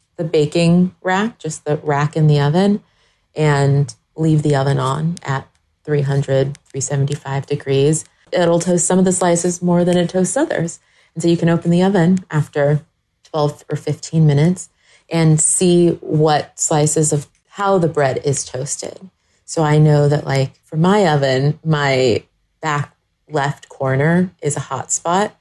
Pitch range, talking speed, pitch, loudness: 145-170 Hz, 160 wpm, 150 Hz, -17 LUFS